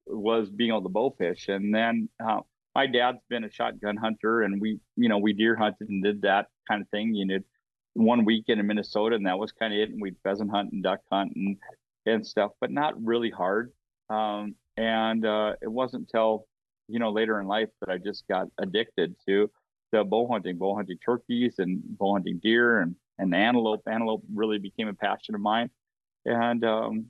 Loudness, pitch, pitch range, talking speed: -27 LUFS, 110 Hz, 100-115 Hz, 205 wpm